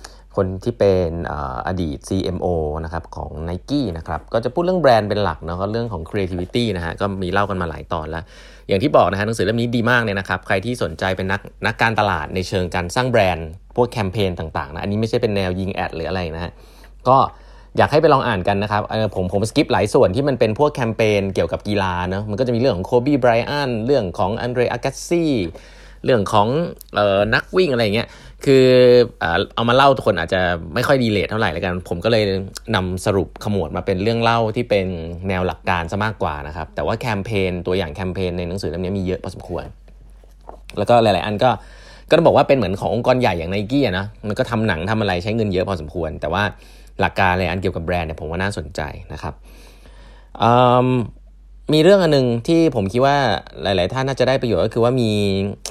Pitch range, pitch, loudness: 90-120 Hz, 100 Hz, -19 LUFS